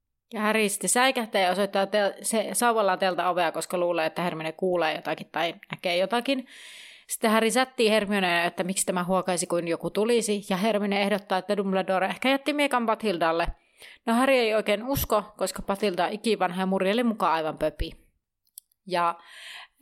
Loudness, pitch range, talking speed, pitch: -25 LUFS, 175-215 Hz, 155 wpm, 195 Hz